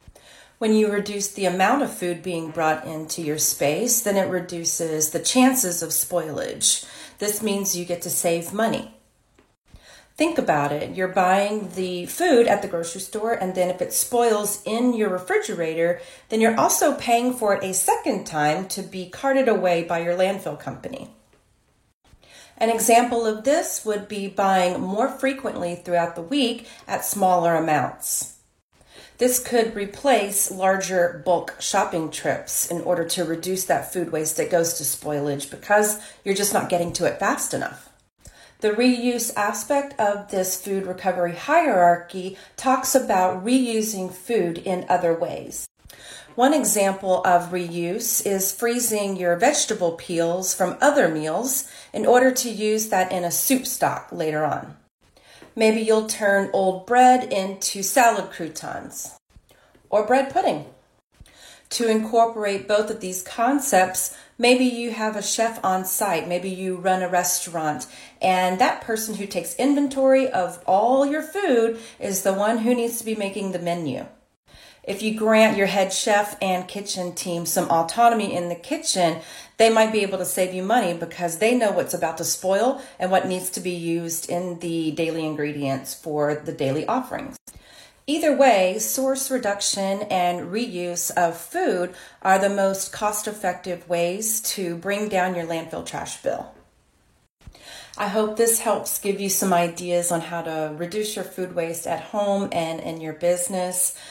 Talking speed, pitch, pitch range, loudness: 160 wpm, 195 Hz, 175-225 Hz, -22 LUFS